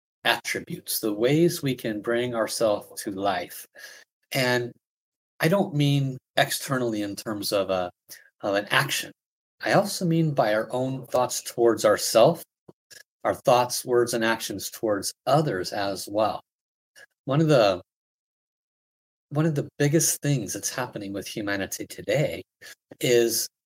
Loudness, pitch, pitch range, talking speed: -25 LUFS, 125 Hz, 110-145 Hz, 135 wpm